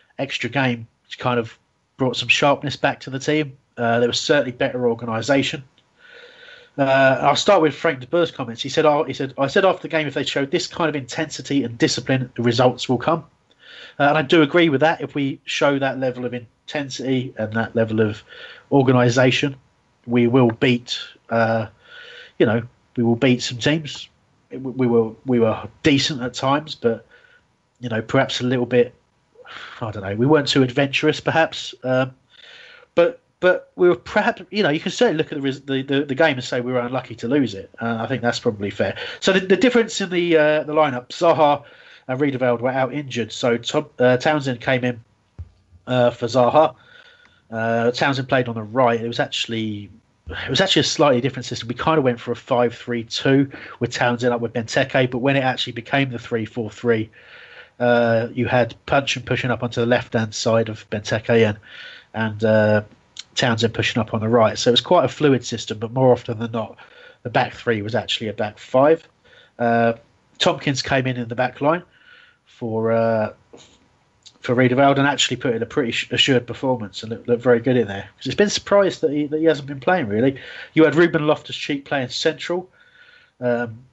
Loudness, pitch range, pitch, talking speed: -20 LUFS, 120-150 Hz, 130 Hz, 200 wpm